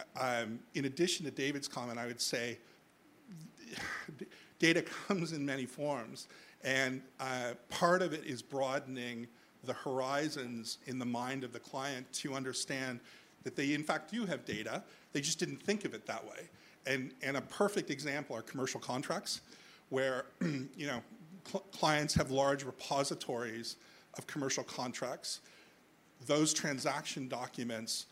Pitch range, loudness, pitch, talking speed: 125-150 Hz, -37 LUFS, 135 Hz, 145 wpm